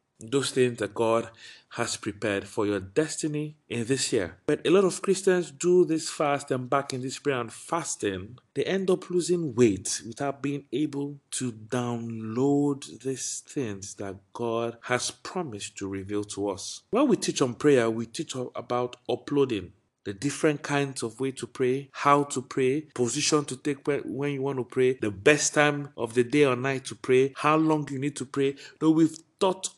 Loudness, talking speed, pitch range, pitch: -27 LUFS, 185 wpm, 120-150 Hz, 135 Hz